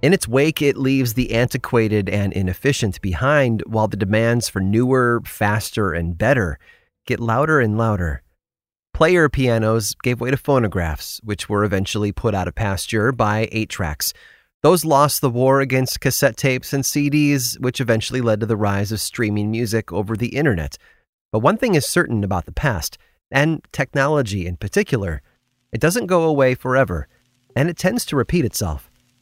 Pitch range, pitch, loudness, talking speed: 105-135 Hz, 120 Hz, -19 LUFS, 170 wpm